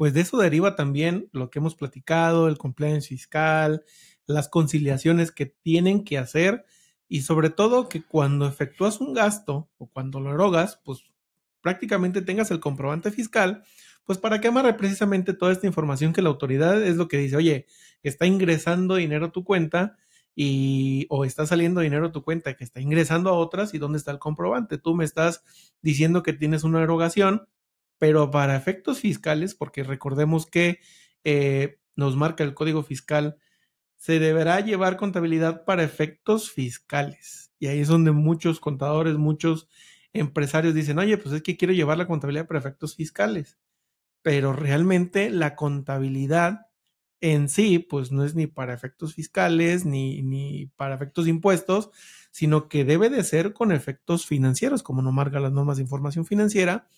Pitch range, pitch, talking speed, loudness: 145-180 Hz, 160 Hz, 165 wpm, -24 LUFS